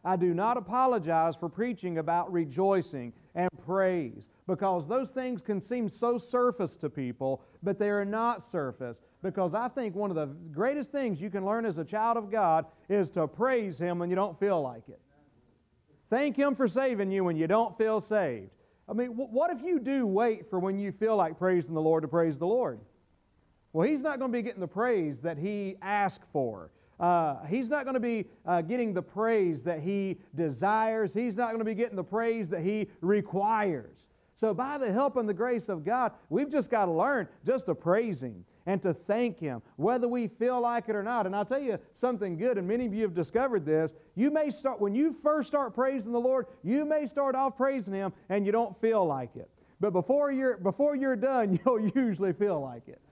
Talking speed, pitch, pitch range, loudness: 215 wpm, 205 Hz, 180-245 Hz, -30 LUFS